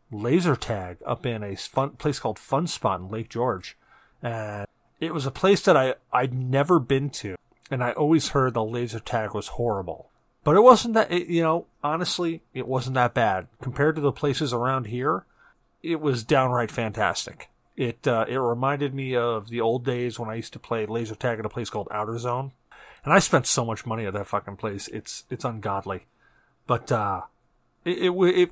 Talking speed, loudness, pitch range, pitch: 200 wpm, -25 LUFS, 115-150 Hz, 125 Hz